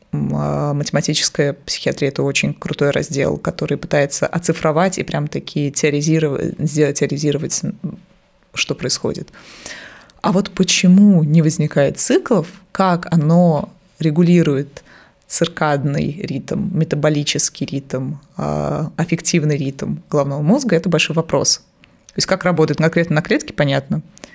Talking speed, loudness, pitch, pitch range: 115 wpm, -17 LUFS, 155 Hz, 145-180 Hz